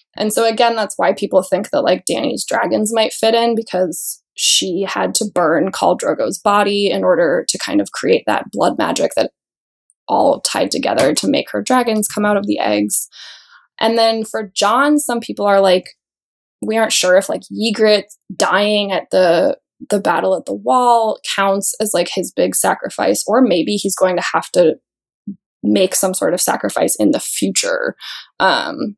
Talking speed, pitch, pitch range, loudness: 180 wpm, 215 Hz, 195-235 Hz, -15 LUFS